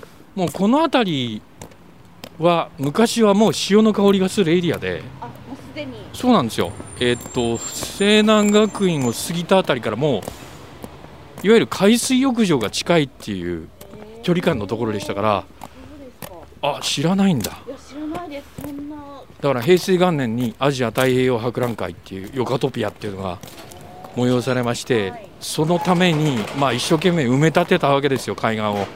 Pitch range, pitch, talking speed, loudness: 120-200 Hz, 155 Hz, 295 characters per minute, -19 LUFS